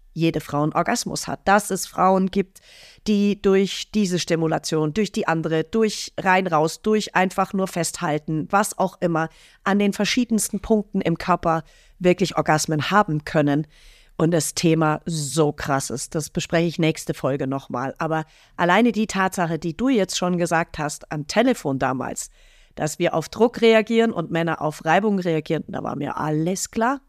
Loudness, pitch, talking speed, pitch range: -22 LUFS, 170 Hz, 165 wpm, 155-195 Hz